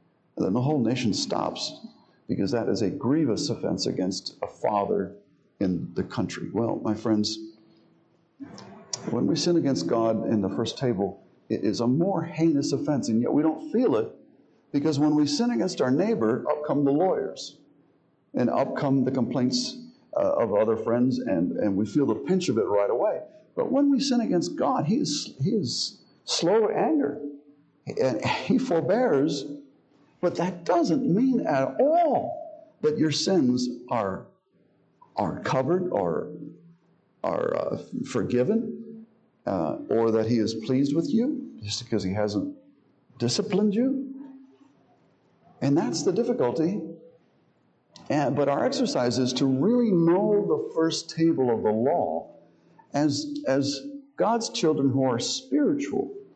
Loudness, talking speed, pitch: -26 LUFS, 155 wpm, 155 Hz